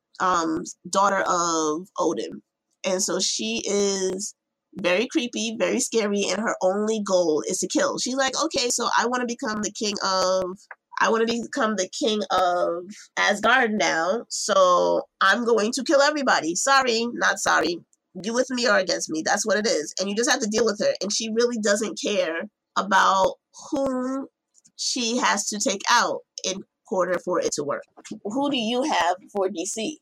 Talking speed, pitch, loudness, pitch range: 175 wpm, 220 Hz, -23 LUFS, 190-265 Hz